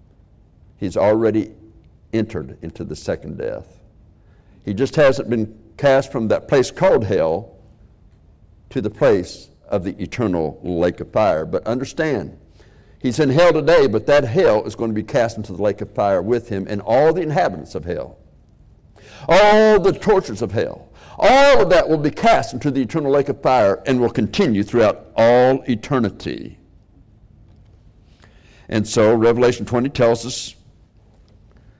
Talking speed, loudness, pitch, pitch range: 155 wpm, -17 LUFS, 110 Hz, 100-125 Hz